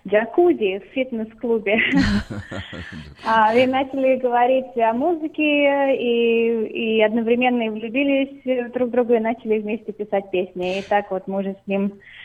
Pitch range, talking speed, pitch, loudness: 200-255 Hz, 125 wpm, 225 Hz, -20 LUFS